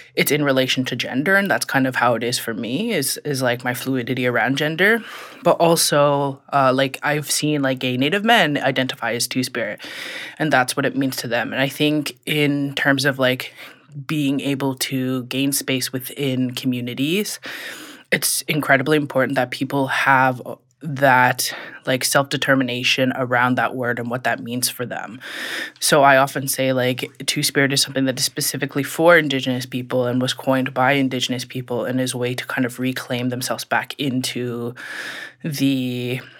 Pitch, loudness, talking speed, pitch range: 130 Hz, -19 LUFS, 175 wpm, 125-140 Hz